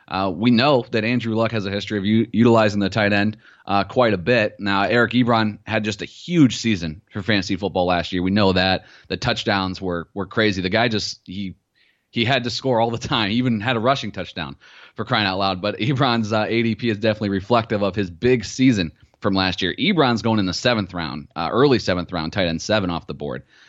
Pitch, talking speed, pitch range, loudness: 105 Hz, 230 wpm, 95-115 Hz, -20 LUFS